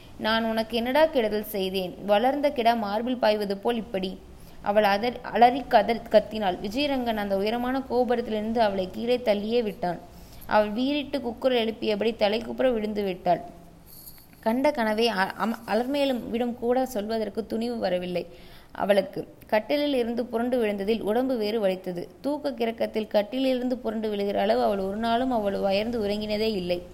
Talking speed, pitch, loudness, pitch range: 135 wpm, 220 Hz, -26 LUFS, 205-245 Hz